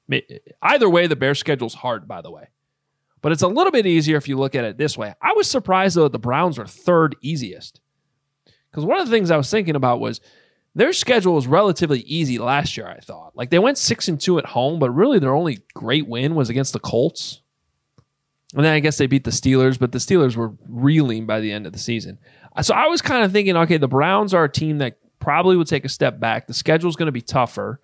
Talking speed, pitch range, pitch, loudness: 245 wpm, 125-170 Hz, 145 Hz, -19 LUFS